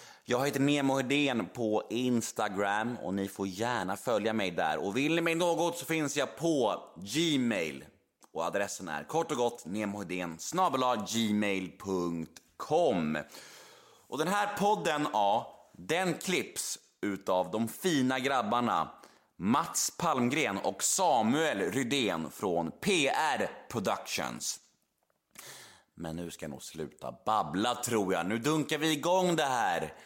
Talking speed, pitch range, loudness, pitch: 130 wpm, 100-155 Hz, -31 LUFS, 125 Hz